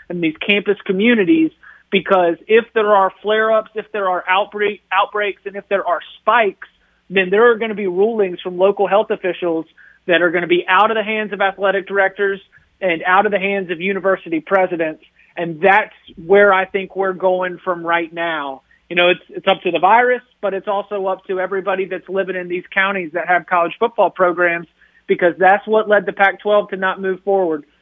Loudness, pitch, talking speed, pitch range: -17 LUFS, 195 Hz, 205 wpm, 180-205 Hz